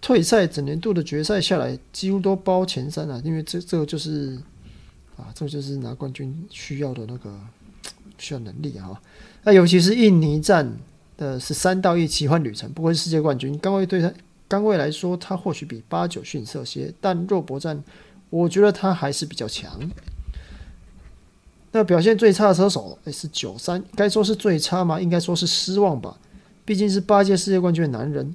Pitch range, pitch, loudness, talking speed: 140-195 Hz, 165 Hz, -21 LUFS, 280 characters per minute